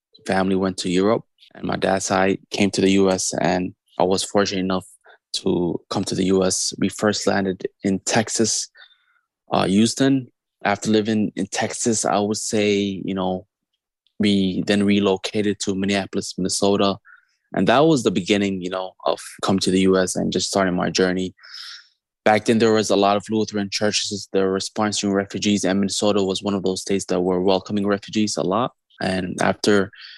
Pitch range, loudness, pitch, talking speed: 95-105 Hz, -21 LUFS, 100 Hz, 175 wpm